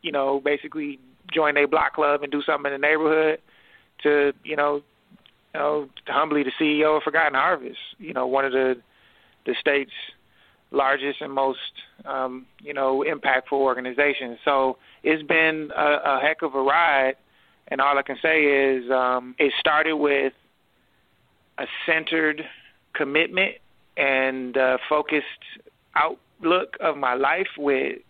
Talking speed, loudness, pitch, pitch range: 145 wpm, -22 LUFS, 145 Hz, 135-155 Hz